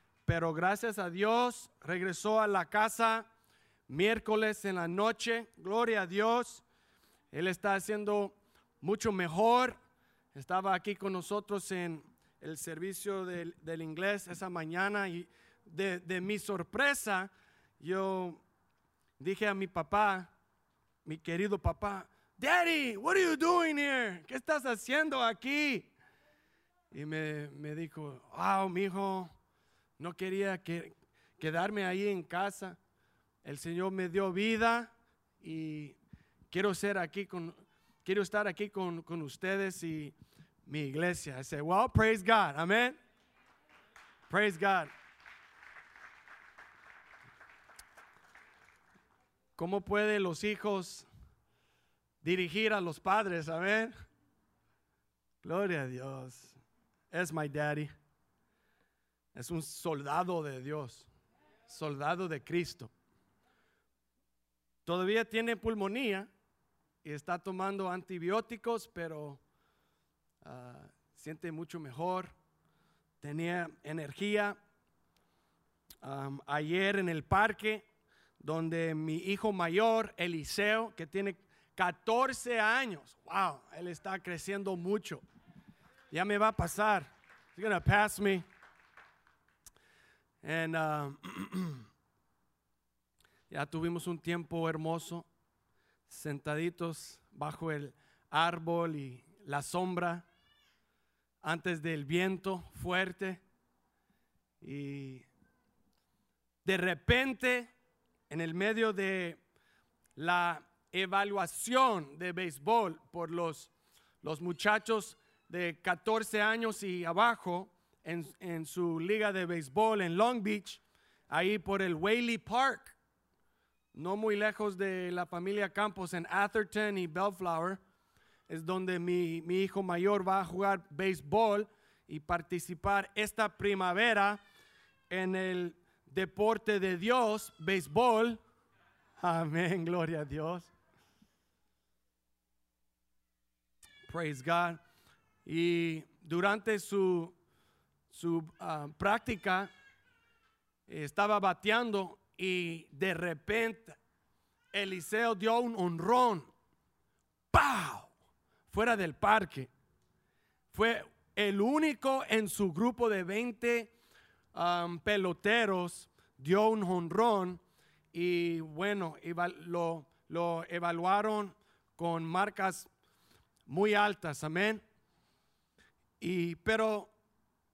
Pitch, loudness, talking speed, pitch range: 185 Hz, -34 LUFS, 100 wpm, 165-210 Hz